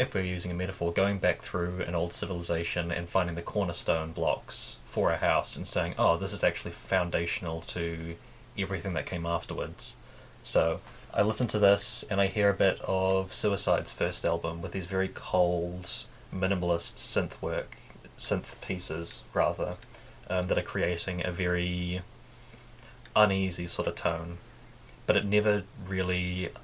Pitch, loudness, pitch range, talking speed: 95 Hz, -30 LUFS, 85-105 Hz, 155 wpm